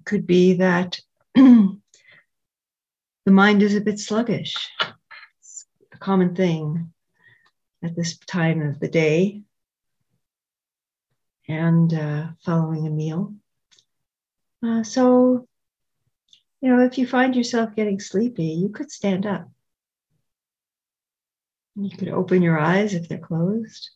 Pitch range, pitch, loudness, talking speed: 165-215 Hz, 190 Hz, -20 LUFS, 115 wpm